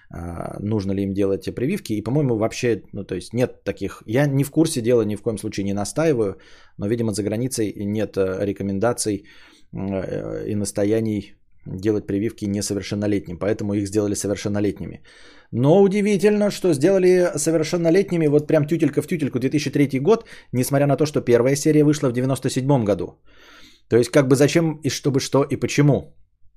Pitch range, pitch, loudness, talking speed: 100-145 Hz, 120 Hz, -21 LUFS, 160 wpm